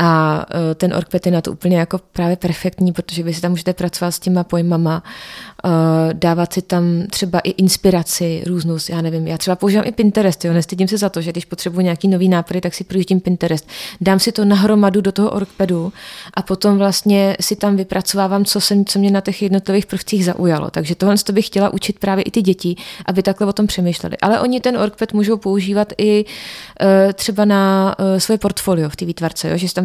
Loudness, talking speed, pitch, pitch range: -16 LUFS, 205 wpm, 190 Hz, 175-200 Hz